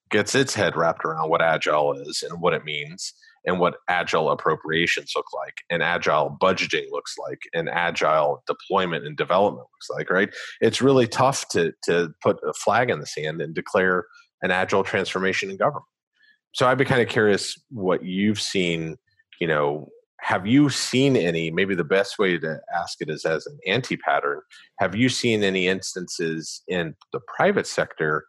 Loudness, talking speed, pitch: -23 LUFS, 180 wpm, 145 Hz